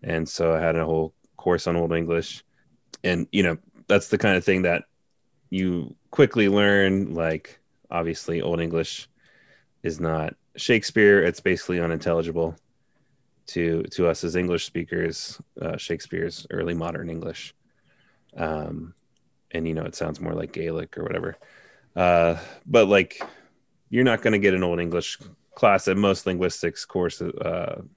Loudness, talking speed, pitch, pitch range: -24 LUFS, 150 wpm, 85 Hz, 80-95 Hz